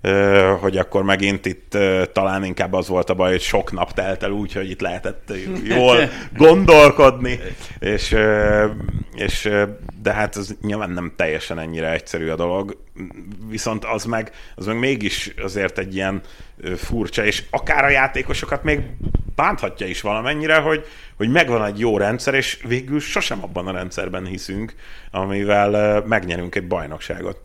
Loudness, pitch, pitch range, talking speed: -18 LUFS, 100 Hz, 95-110 Hz, 150 wpm